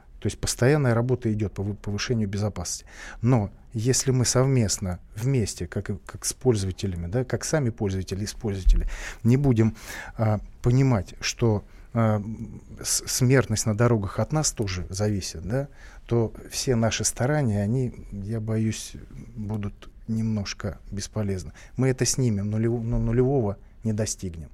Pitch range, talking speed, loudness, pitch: 100-120 Hz, 130 wpm, -26 LUFS, 110 Hz